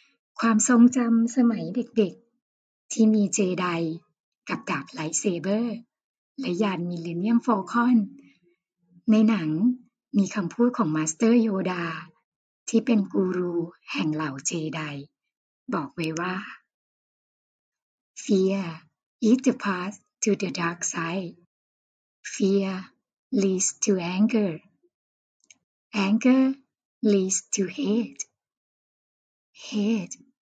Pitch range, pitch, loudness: 175-230 Hz, 200 Hz, -25 LUFS